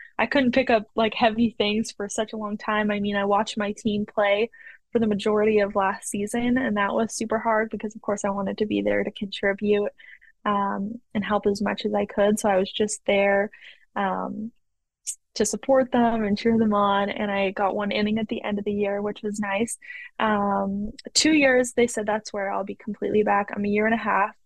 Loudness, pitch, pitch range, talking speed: -24 LUFS, 210 Hz, 205-225 Hz, 225 wpm